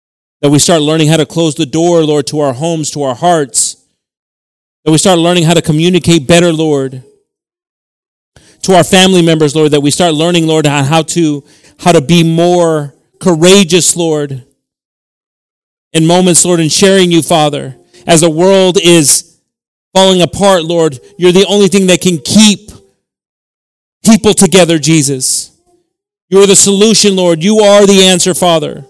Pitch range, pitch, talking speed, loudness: 155-190 Hz, 170 Hz, 160 wpm, -8 LUFS